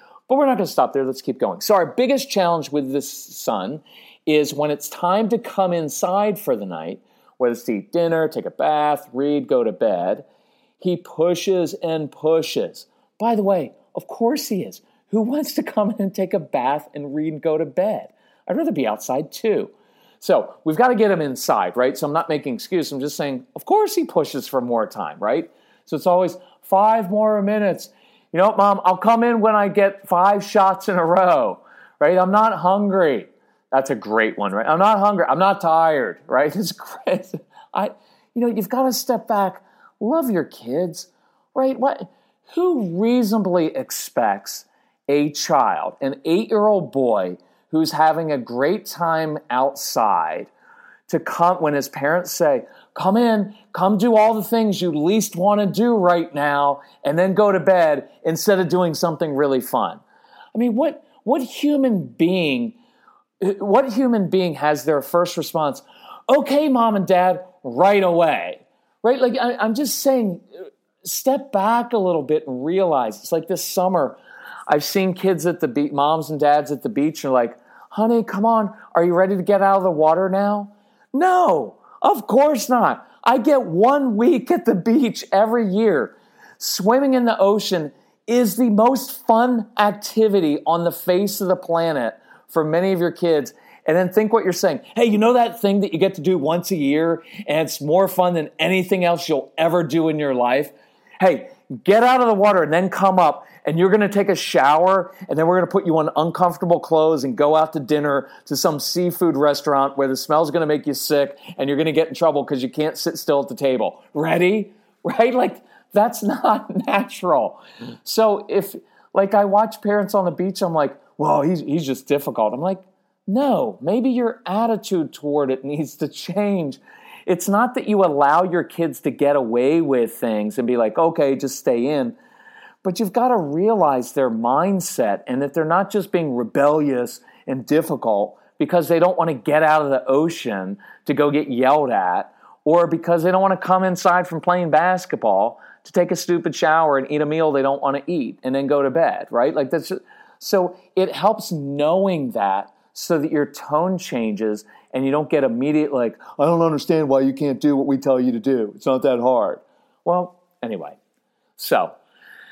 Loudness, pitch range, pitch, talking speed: -19 LUFS, 150-215 Hz, 180 Hz, 195 wpm